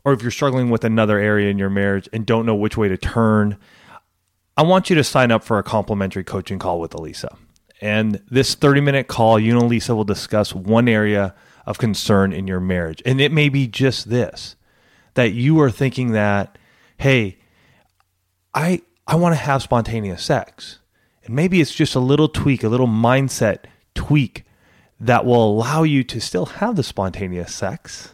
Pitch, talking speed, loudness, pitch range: 115 Hz, 180 wpm, -18 LUFS, 100-135 Hz